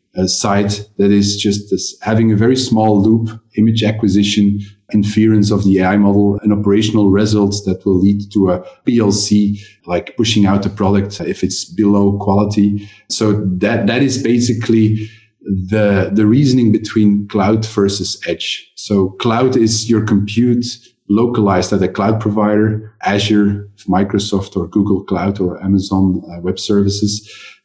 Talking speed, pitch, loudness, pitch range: 145 wpm, 105 Hz, -14 LUFS, 100-110 Hz